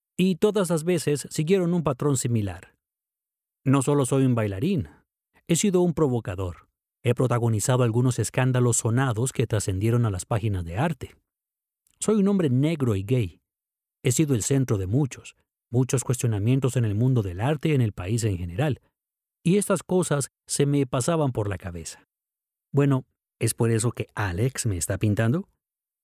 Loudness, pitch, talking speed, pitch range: -24 LUFS, 130 Hz, 165 wpm, 110-150 Hz